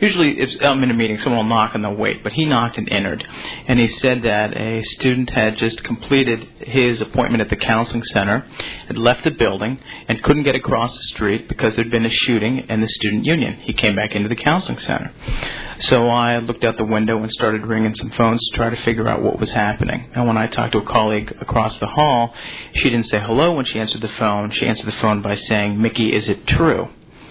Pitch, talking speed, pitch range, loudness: 115 Hz, 235 wpm, 110-120 Hz, -18 LUFS